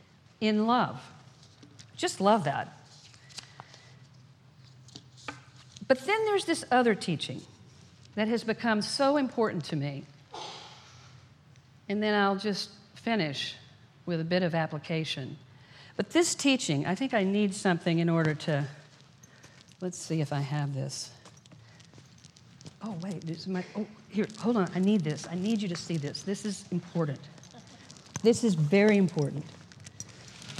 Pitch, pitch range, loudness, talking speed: 155 Hz, 140-200 Hz, -29 LUFS, 135 wpm